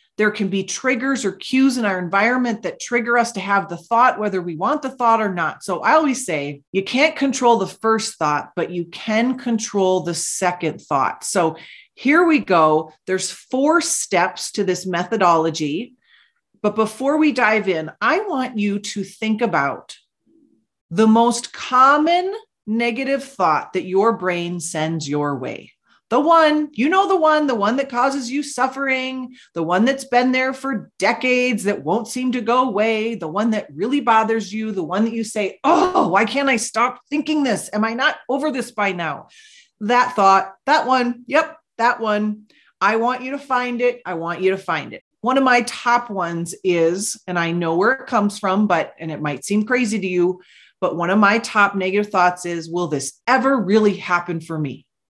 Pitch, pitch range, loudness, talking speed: 220 Hz, 185-255 Hz, -19 LUFS, 190 wpm